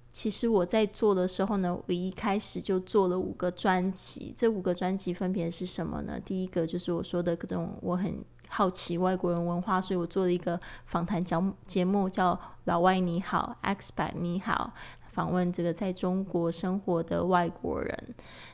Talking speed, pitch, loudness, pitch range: 275 characters per minute, 180 Hz, -30 LUFS, 175-195 Hz